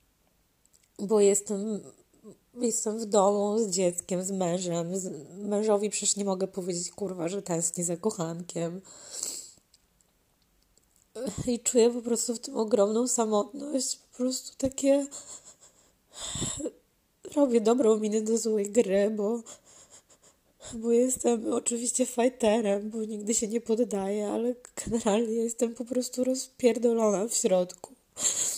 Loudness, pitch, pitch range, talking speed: -28 LUFS, 220 Hz, 195-240 Hz, 115 wpm